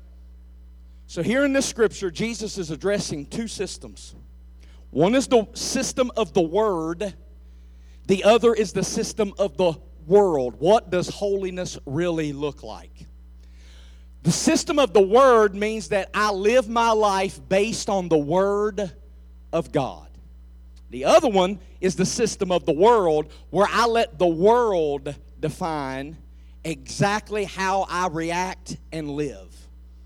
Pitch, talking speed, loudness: 185 Hz, 140 wpm, -22 LUFS